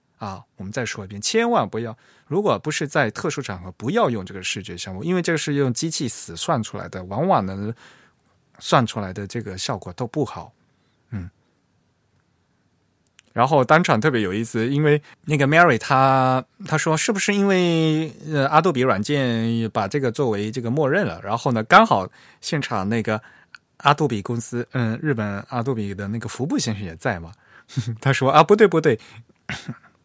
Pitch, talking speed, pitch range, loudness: 120 Hz, 275 characters per minute, 105-150 Hz, -21 LUFS